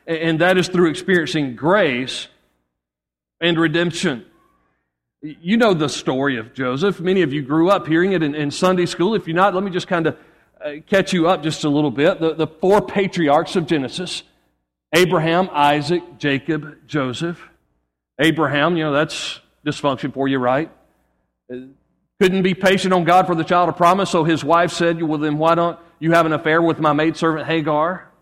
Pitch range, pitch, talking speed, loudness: 145-175 Hz, 160 Hz, 175 wpm, -18 LUFS